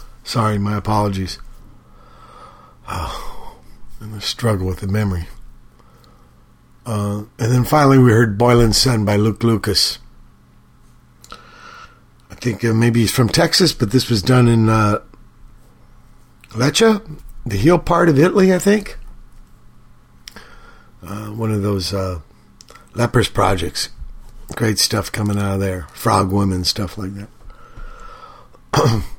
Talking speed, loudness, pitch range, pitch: 125 wpm, -17 LUFS, 100-120 Hz, 110 Hz